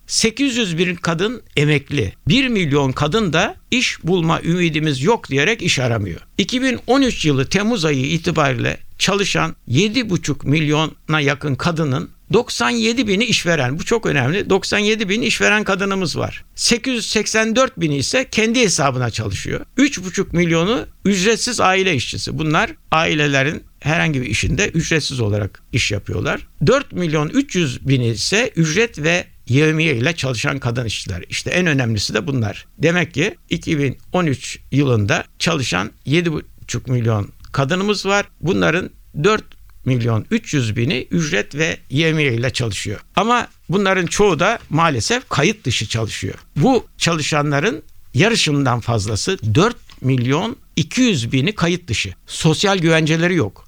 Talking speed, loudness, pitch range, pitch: 125 wpm, -18 LUFS, 130-195 Hz, 160 Hz